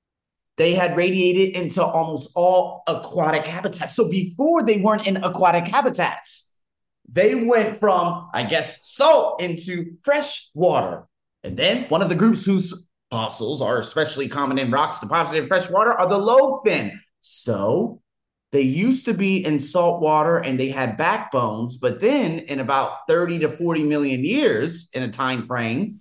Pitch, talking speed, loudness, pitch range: 175 Hz, 160 wpm, -20 LUFS, 150-195 Hz